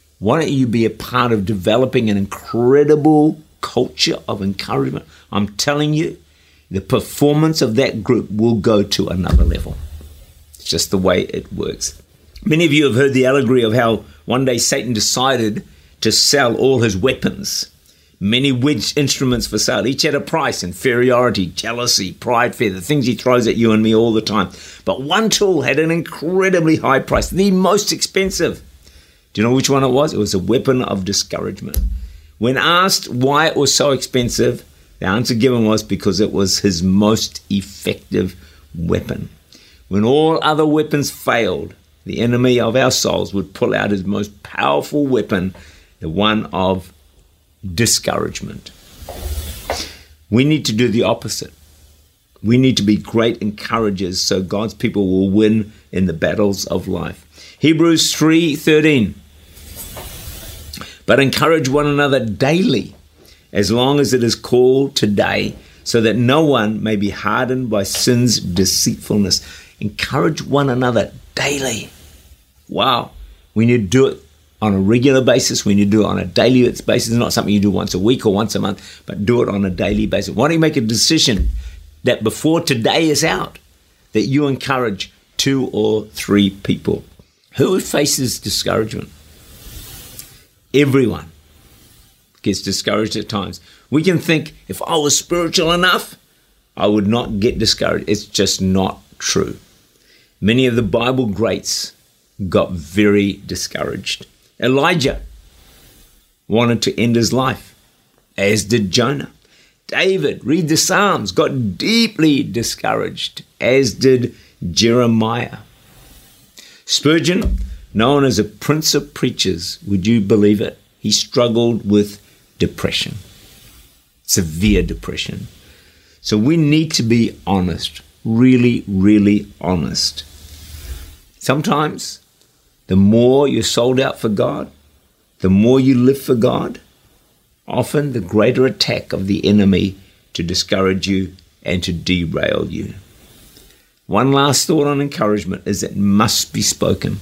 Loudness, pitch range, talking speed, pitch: -16 LUFS, 95-130 Hz, 145 wpm, 110 Hz